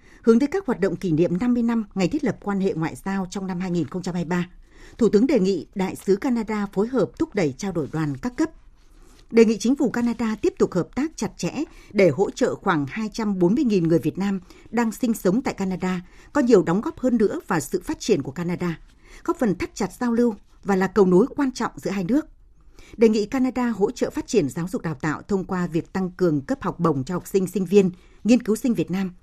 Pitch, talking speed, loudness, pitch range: 205 Hz, 235 wpm, -23 LUFS, 180-245 Hz